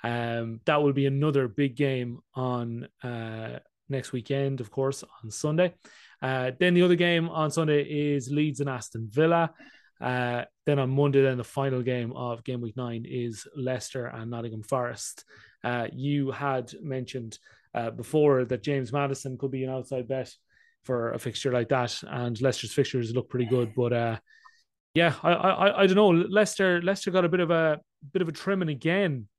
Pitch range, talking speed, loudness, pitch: 120-155 Hz, 180 wpm, -27 LUFS, 135 Hz